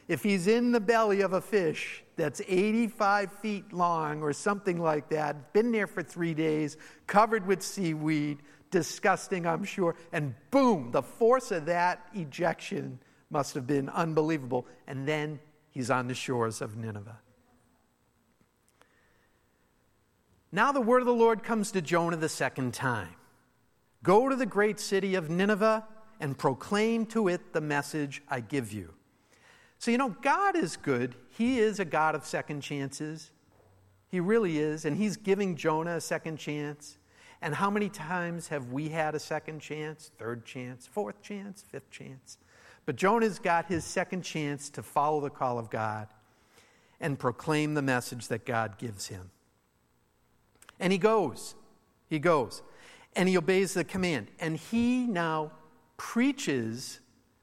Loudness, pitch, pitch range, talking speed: -30 LUFS, 155 Hz, 135-200 Hz, 155 wpm